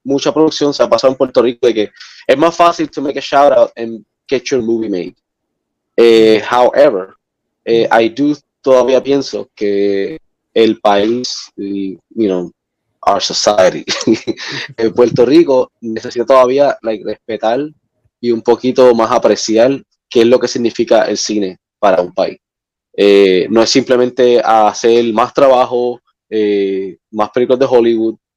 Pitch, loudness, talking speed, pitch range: 120 Hz, -12 LUFS, 150 wpm, 110-130 Hz